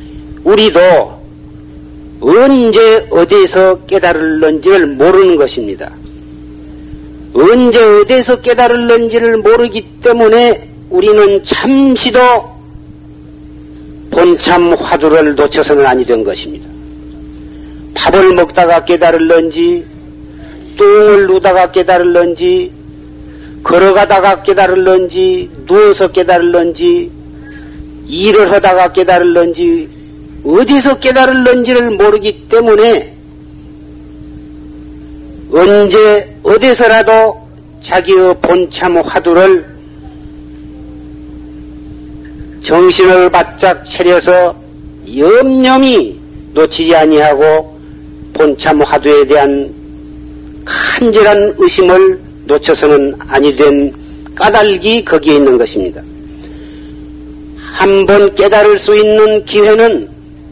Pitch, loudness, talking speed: 170 Hz, -7 LUFS, 200 characters per minute